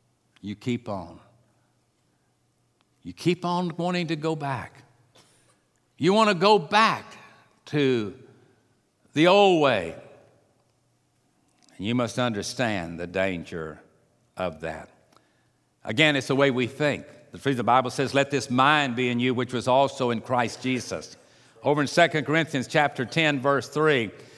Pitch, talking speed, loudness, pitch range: 130 Hz, 145 wpm, -24 LUFS, 120-150 Hz